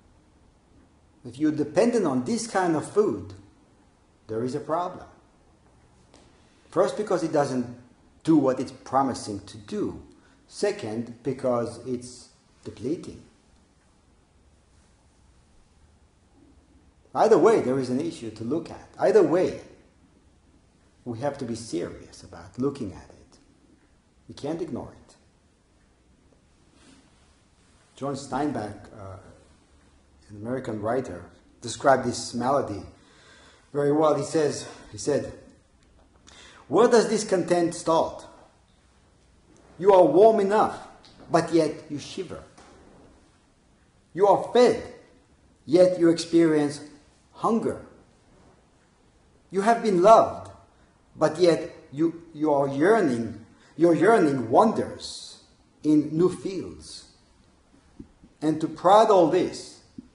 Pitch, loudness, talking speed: 125 Hz, -24 LUFS, 105 wpm